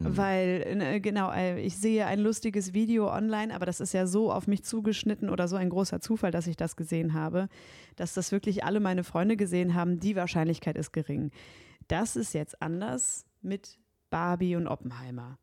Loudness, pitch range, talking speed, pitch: -30 LUFS, 170-205 Hz, 180 wpm, 185 Hz